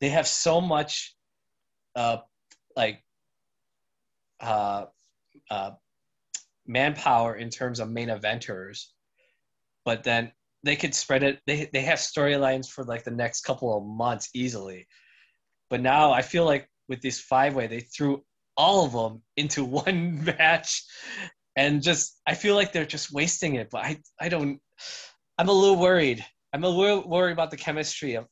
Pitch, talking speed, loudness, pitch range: 140 Hz, 155 wpm, -25 LUFS, 115-155 Hz